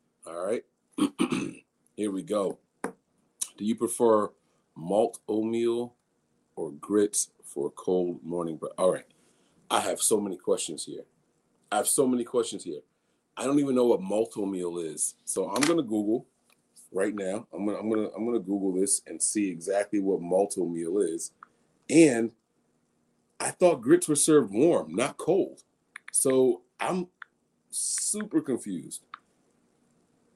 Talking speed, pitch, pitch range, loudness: 150 wpm, 115 Hz, 100-165 Hz, -27 LUFS